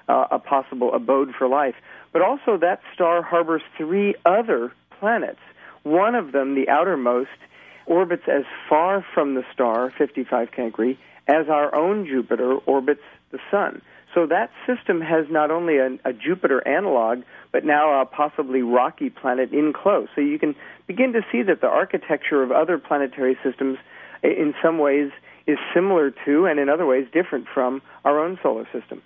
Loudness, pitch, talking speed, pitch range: -21 LUFS, 145 Hz, 165 wpm, 130-165 Hz